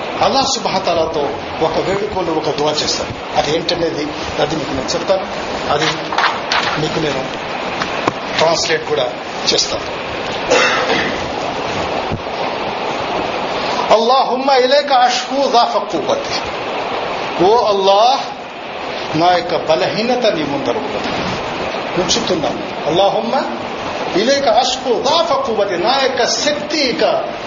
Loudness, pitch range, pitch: -16 LUFS, 165-270 Hz, 215 Hz